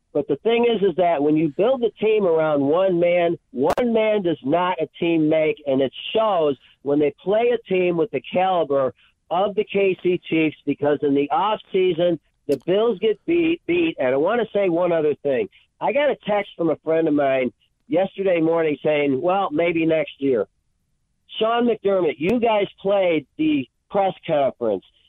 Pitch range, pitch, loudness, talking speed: 155-215 Hz, 180 Hz, -21 LUFS, 185 wpm